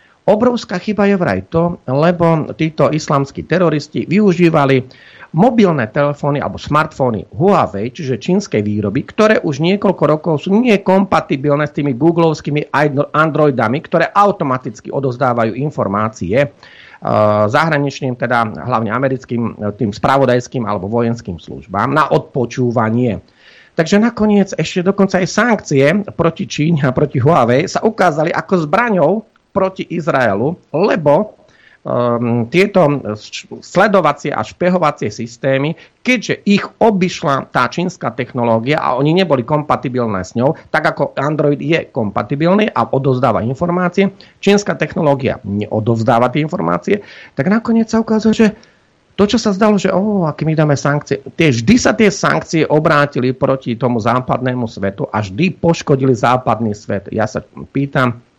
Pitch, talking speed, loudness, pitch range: 150 Hz, 130 wpm, -15 LUFS, 125-180 Hz